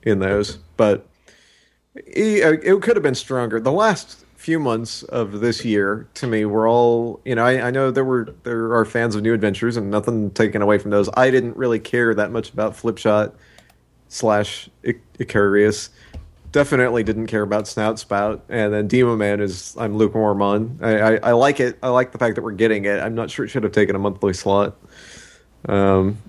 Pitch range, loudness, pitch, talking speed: 105-120 Hz, -19 LUFS, 110 Hz, 205 wpm